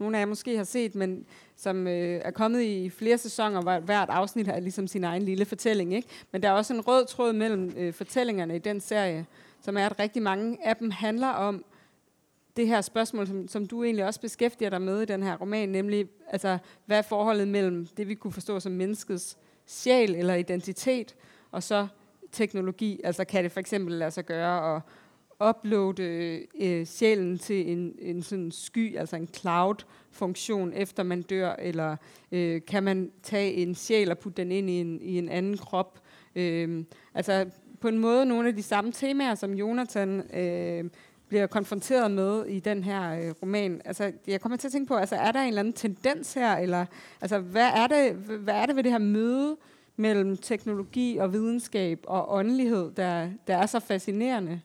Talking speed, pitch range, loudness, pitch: 195 wpm, 180-220 Hz, -28 LUFS, 200 Hz